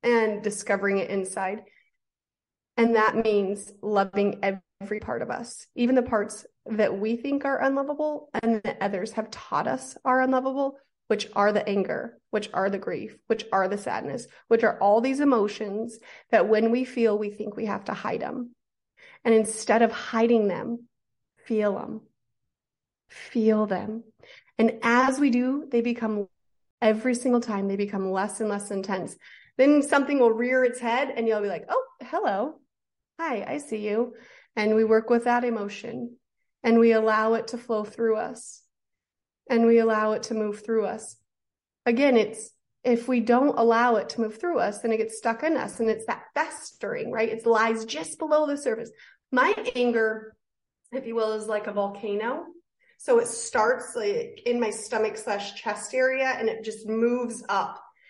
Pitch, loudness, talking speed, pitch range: 225 Hz, -25 LUFS, 175 wpm, 210-245 Hz